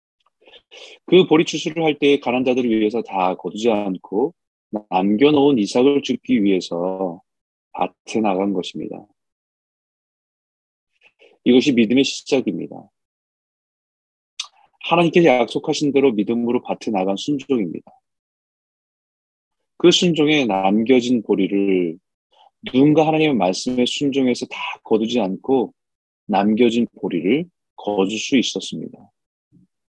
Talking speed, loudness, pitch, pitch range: 245 characters per minute, -18 LUFS, 125 Hz, 105-155 Hz